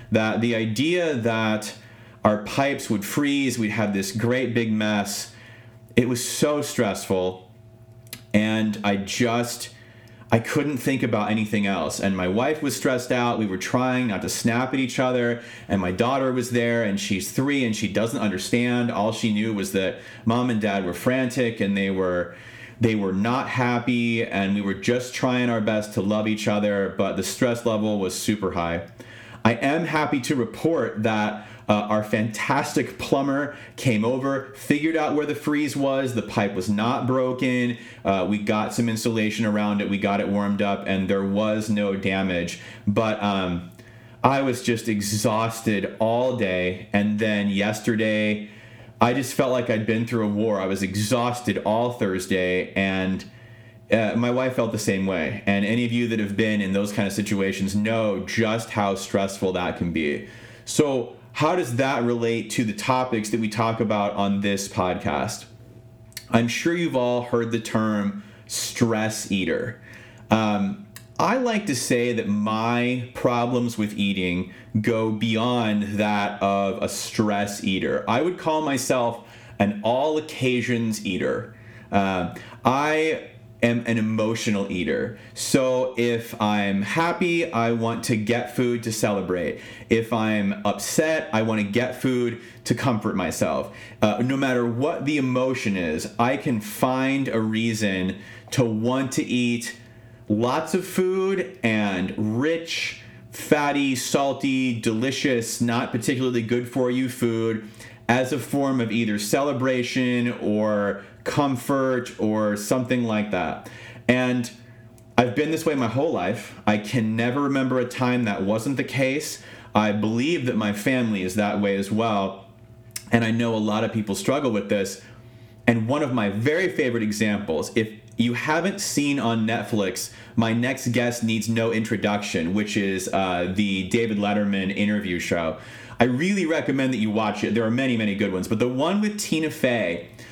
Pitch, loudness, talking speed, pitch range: 115 Hz, -24 LUFS, 165 wpm, 105-125 Hz